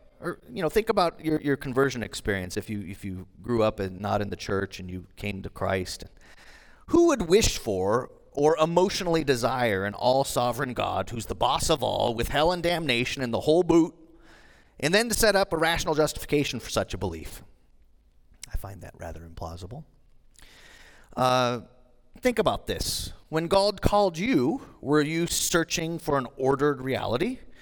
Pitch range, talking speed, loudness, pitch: 100-160 Hz, 175 wpm, -26 LUFS, 125 Hz